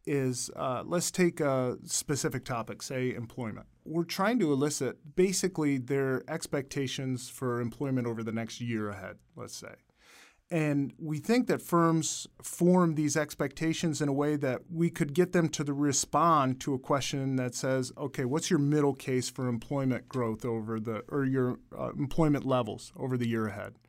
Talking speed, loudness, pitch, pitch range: 170 wpm, -30 LUFS, 140 Hz, 125-155 Hz